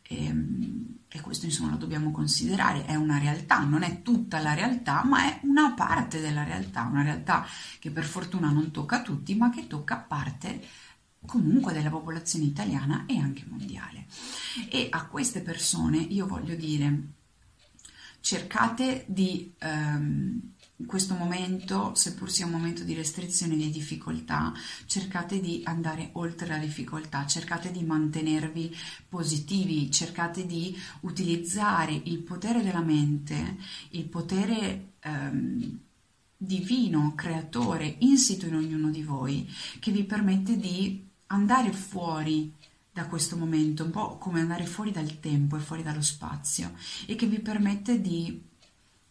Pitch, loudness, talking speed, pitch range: 165 Hz, -29 LUFS, 140 wpm, 150-195 Hz